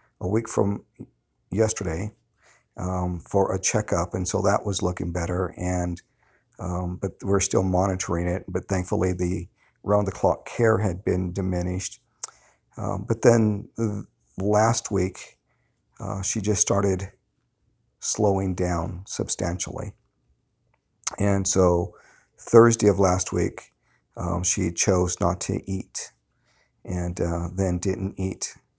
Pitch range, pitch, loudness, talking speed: 90-105 Hz, 95 Hz, -25 LUFS, 125 wpm